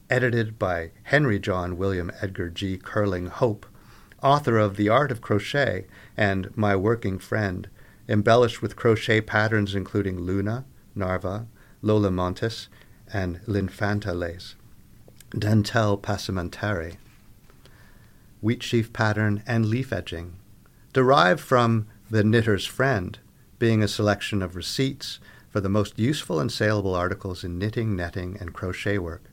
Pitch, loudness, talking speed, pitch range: 105 Hz, -25 LUFS, 125 wpm, 95-115 Hz